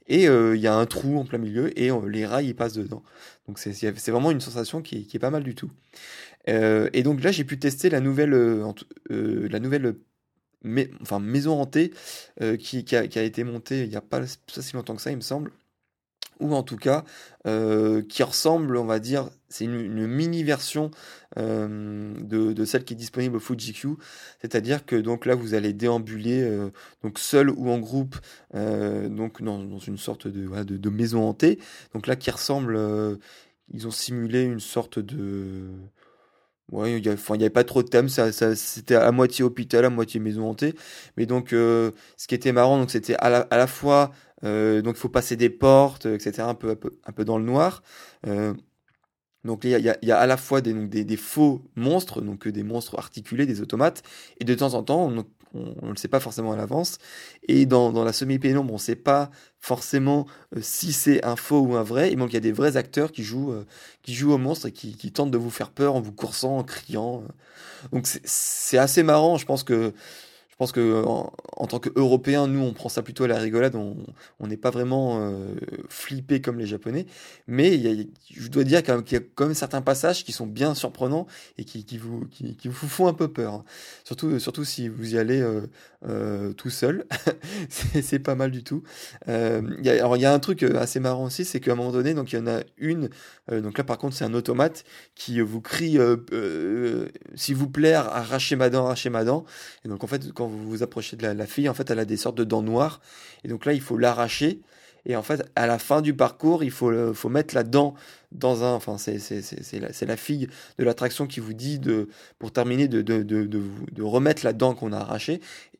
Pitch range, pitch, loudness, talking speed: 110-140 Hz, 120 Hz, -24 LUFS, 230 wpm